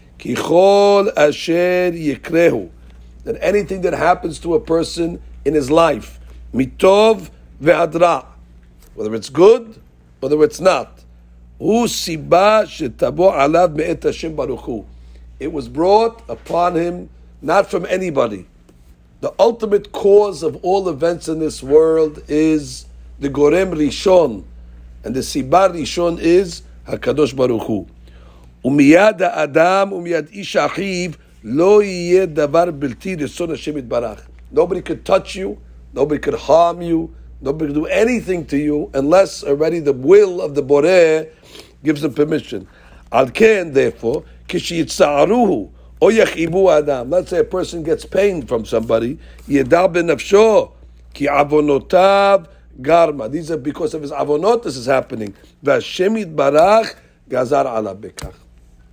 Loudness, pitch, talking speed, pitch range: -16 LUFS, 155 Hz, 120 wpm, 115-180 Hz